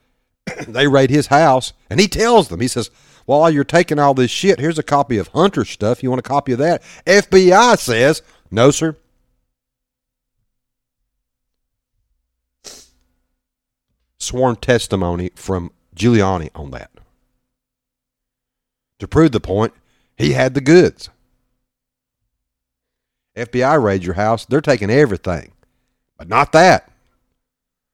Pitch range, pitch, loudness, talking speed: 95-140 Hz, 125 Hz, -15 LUFS, 120 wpm